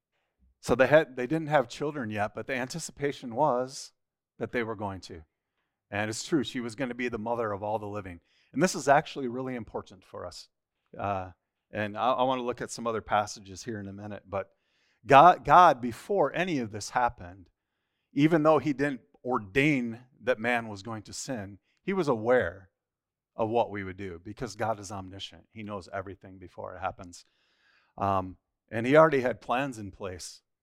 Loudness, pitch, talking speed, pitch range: -28 LUFS, 115 Hz, 195 wpm, 100-130 Hz